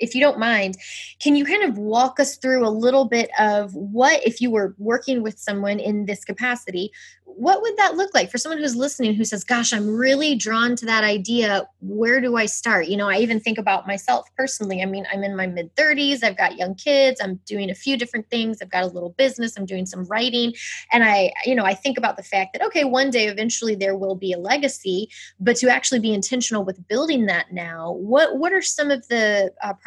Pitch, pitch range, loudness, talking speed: 225 Hz, 200-260 Hz, -20 LUFS, 235 wpm